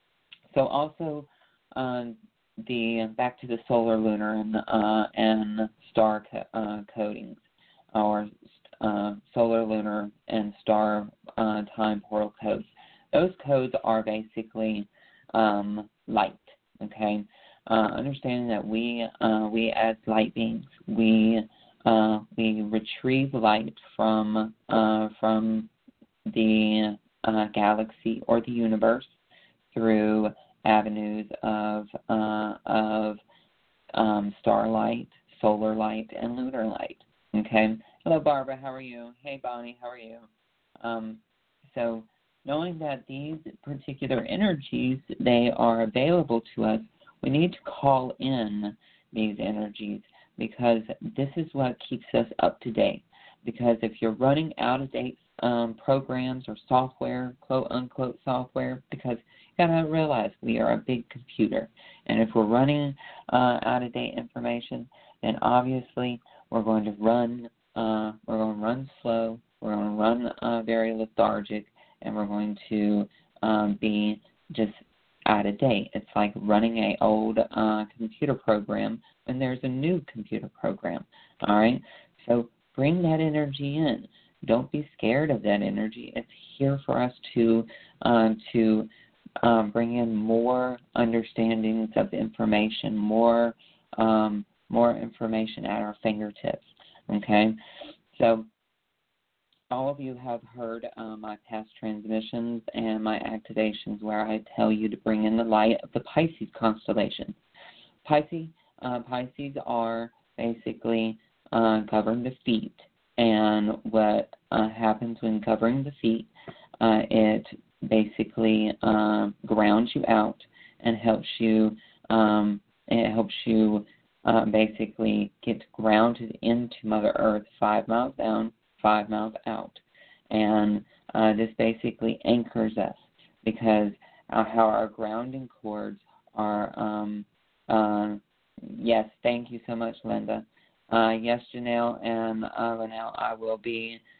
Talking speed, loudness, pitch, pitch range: 130 wpm, -27 LUFS, 110 Hz, 110-120 Hz